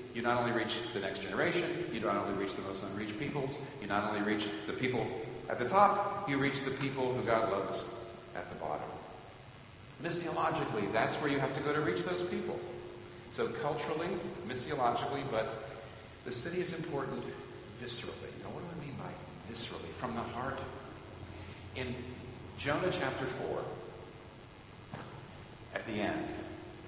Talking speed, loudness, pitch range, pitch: 160 wpm, -36 LUFS, 110-140 Hz, 125 Hz